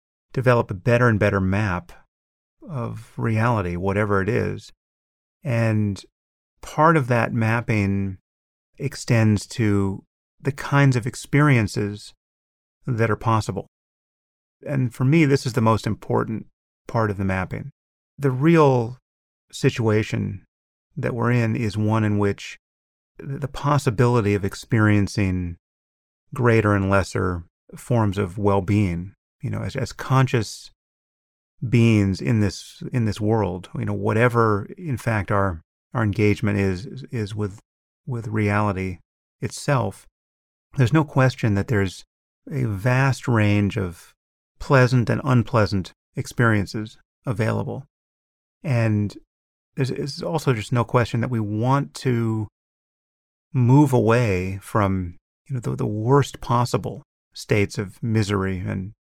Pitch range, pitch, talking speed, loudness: 95-125 Hz, 110 Hz, 125 wpm, -22 LUFS